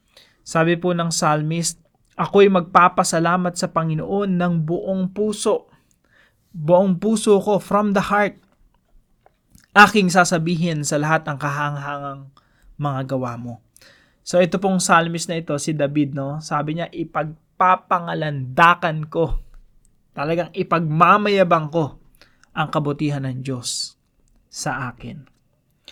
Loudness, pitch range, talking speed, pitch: -19 LUFS, 145-185 Hz, 110 wpm, 165 Hz